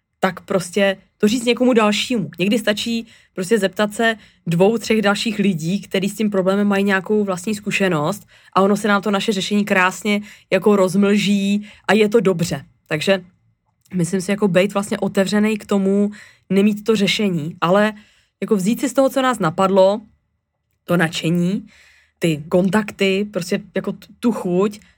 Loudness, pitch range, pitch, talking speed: -18 LUFS, 190-215 Hz, 200 Hz, 160 wpm